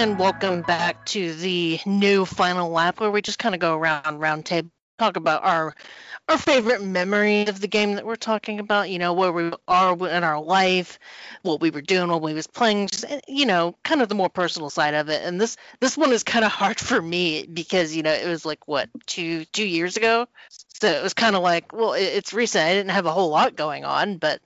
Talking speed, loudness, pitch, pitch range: 240 wpm, -22 LUFS, 185 Hz, 170-210 Hz